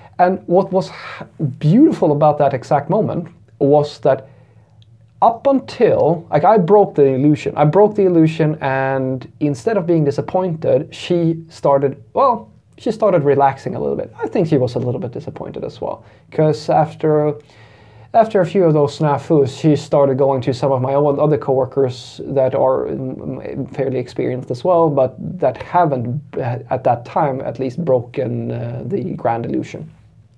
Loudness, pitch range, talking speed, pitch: -17 LUFS, 130-165 Hz, 160 wpm, 145 Hz